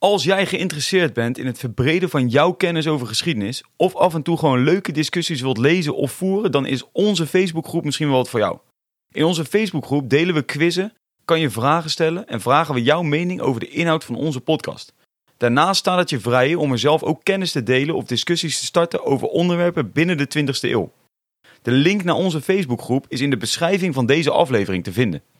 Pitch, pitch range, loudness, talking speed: 155 Hz, 135-175 Hz, -19 LUFS, 210 wpm